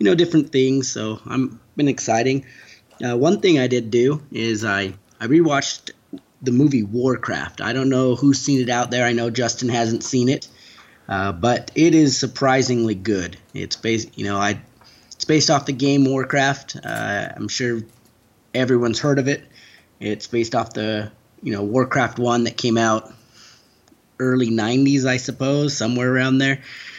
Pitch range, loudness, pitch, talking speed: 110-135 Hz, -20 LUFS, 120 Hz, 170 wpm